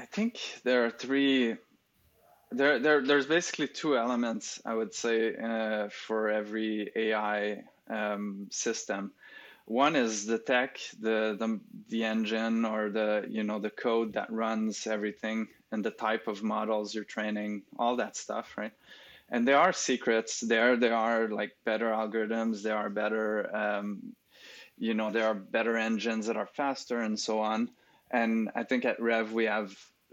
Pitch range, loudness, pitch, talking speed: 110-115 Hz, -30 LUFS, 110 Hz, 160 wpm